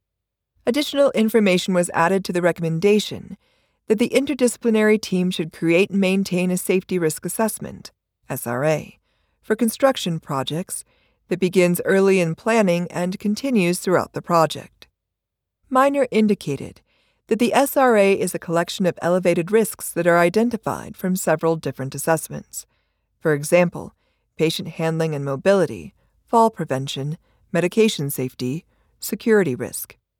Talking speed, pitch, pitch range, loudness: 125 wpm, 180 Hz, 160-215 Hz, -20 LUFS